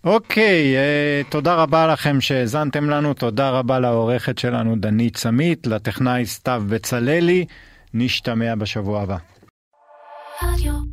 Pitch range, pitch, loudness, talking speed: 115-145 Hz, 125 Hz, -19 LUFS, 100 wpm